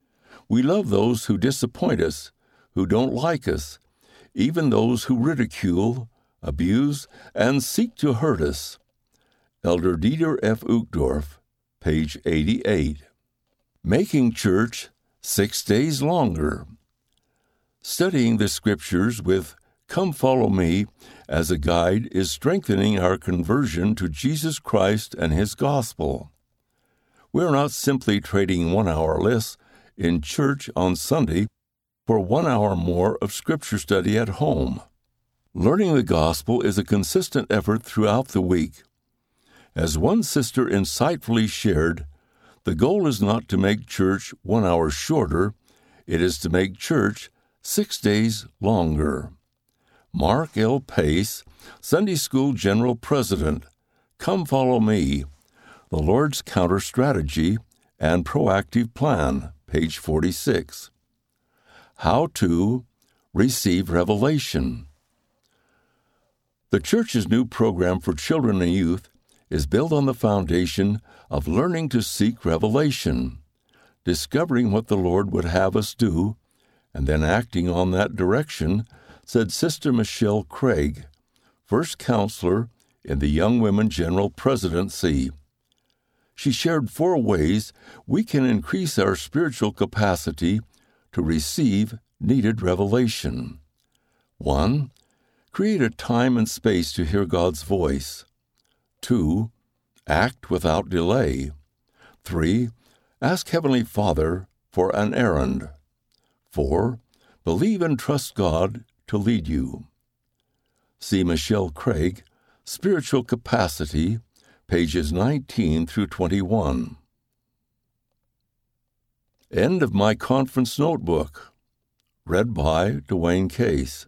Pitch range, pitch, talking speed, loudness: 85-125 Hz, 105 Hz, 115 wpm, -23 LUFS